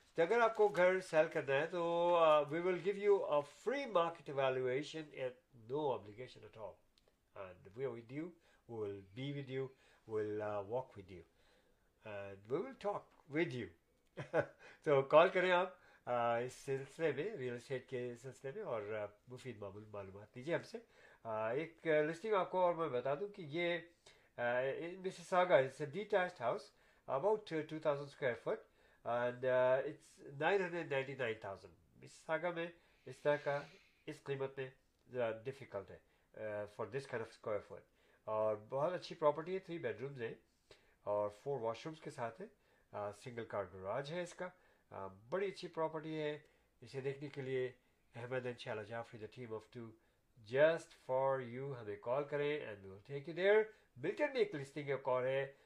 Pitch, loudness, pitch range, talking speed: 135 Hz, -39 LUFS, 120-170 Hz, 120 wpm